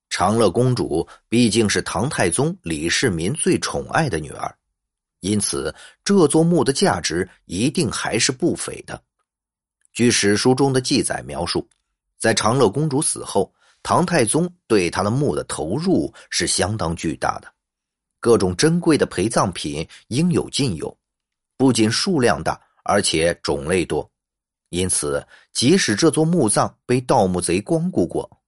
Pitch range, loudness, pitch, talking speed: 105-160 Hz, -20 LUFS, 125 Hz, 215 characters per minute